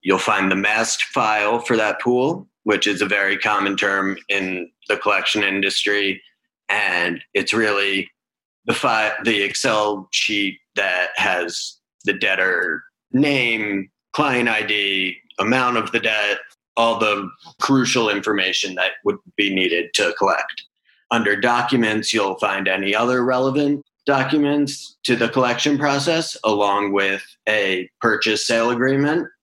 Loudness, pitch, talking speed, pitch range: -19 LUFS, 110 Hz, 135 wpm, 100-130 Hz